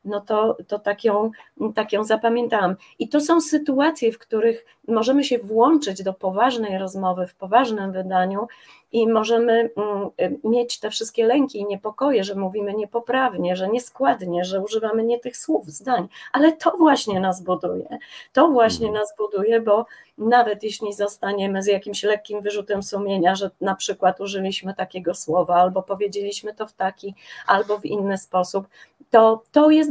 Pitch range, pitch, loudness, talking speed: 195-230 Hz, 210 Hz, -21 LUFS, 155 wpm